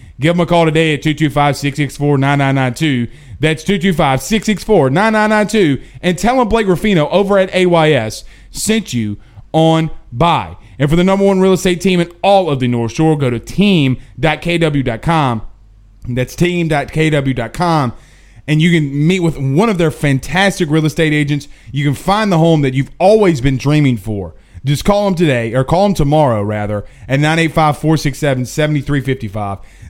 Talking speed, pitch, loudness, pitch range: 160 wpm, 150 Hz, -14 LUFS, 130-175 Hz